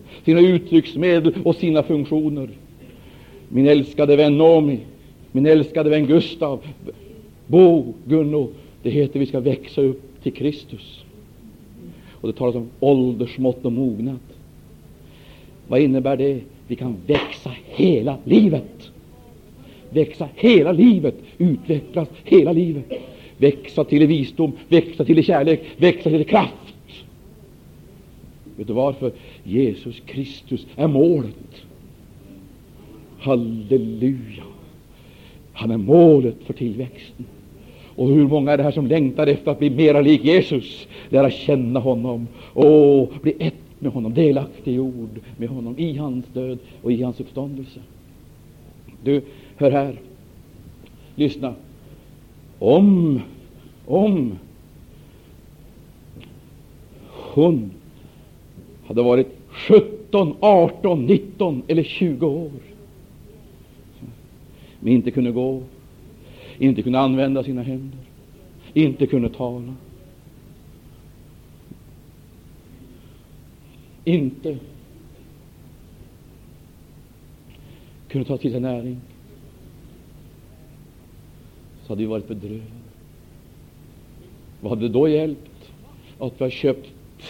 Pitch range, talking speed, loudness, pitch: 125-155 Hz, 100 wpm, -18 LUFS, 135 Hz